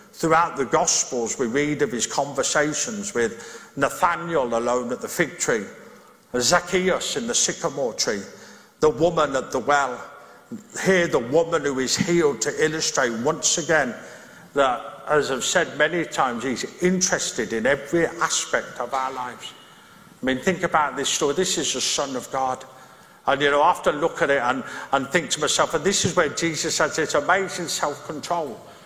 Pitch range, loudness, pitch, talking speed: 135-180 Hz, -22 LUFS, 155 Hz, 175 wpm